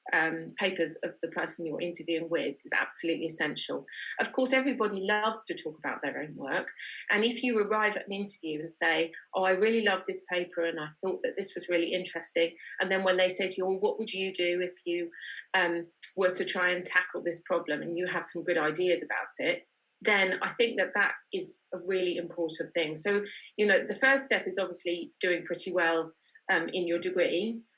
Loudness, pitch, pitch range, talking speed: -30 LUFS, 180 Hz, 170-200 Hz, 215 wpm